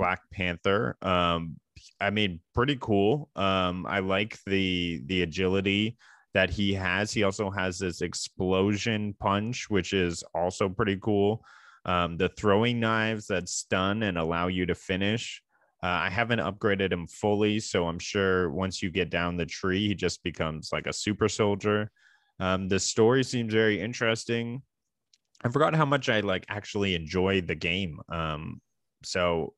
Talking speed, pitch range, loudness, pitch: 160 wpm, 90-105 Hz, -28 LUFS, 100 Hz